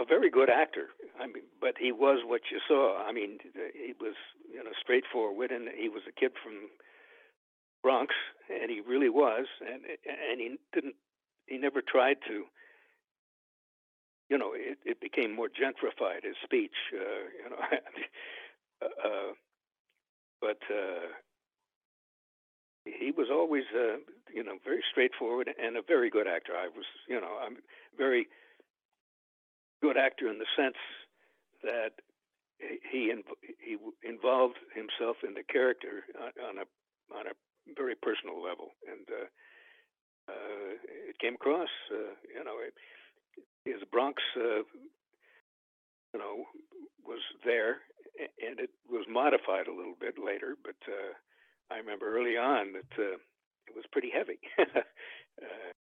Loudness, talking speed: -33 LUFS, 140 wpm